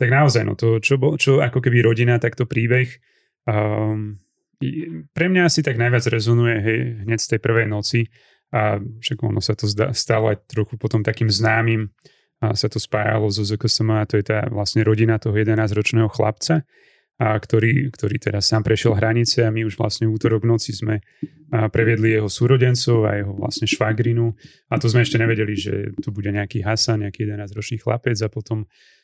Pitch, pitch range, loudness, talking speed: 115 Hz, 110-120 Hz, -19 LUFS, 180 wpm